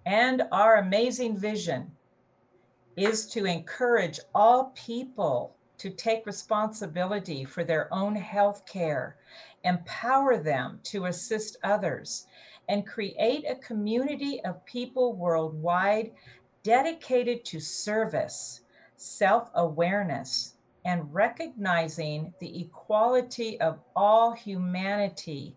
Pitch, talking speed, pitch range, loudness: 205 Hz, 95 wpm, 175-230 Hz, -28 LUFS